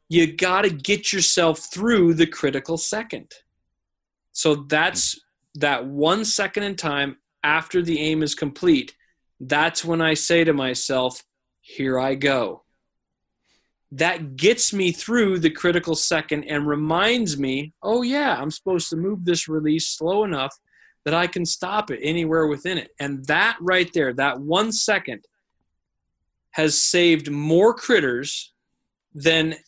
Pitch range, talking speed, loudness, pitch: 145-185 Hz, 140 wpm, -21 LUFS, 165 Hz